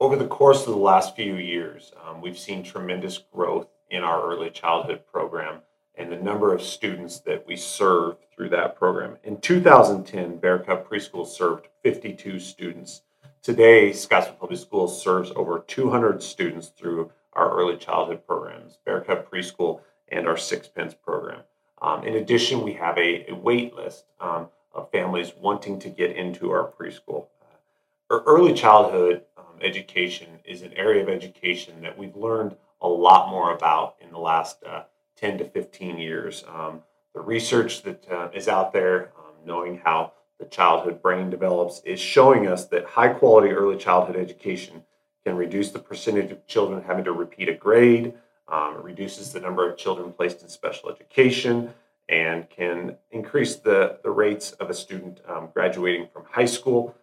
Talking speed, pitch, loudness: 165 wpm, 100 Hz, -22 LUFS